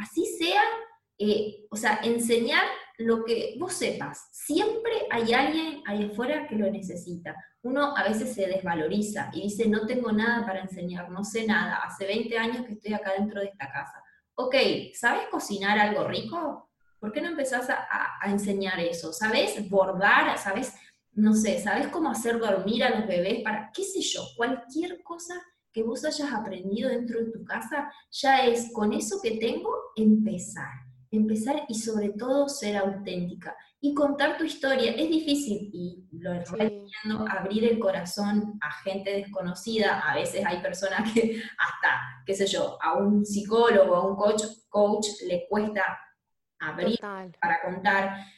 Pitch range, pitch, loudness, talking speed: 195-255 Hz, 215 Hz, -27 LUFS, 165 wpm